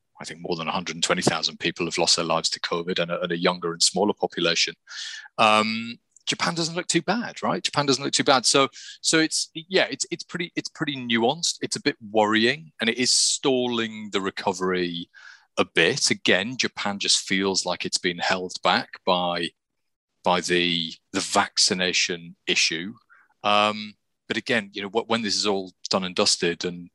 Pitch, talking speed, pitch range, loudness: 110 Hz, 185 wpm, 90-145 Hz, -23 LUFS